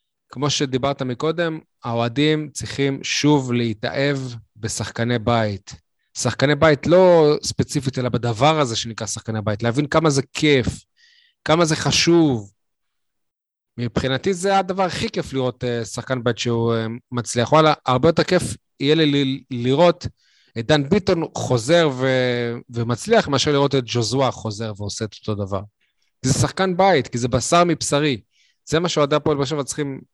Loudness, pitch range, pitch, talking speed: -20 LUFS, 120-155 Hz, 135 Hz, 145 wpm